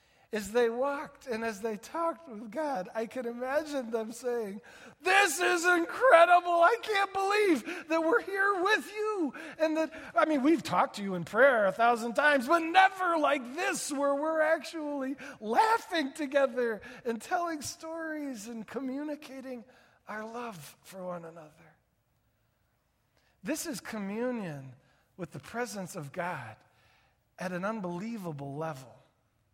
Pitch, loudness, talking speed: 250 Hz, -29 LUFS, 140 wpm